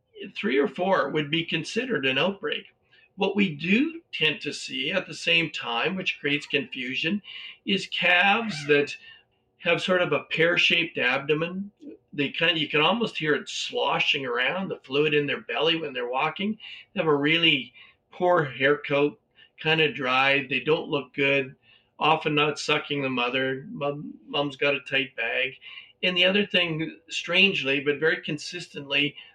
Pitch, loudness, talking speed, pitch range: 155 Hz, -24 LUFS, 165 wpm, 145-185 Hz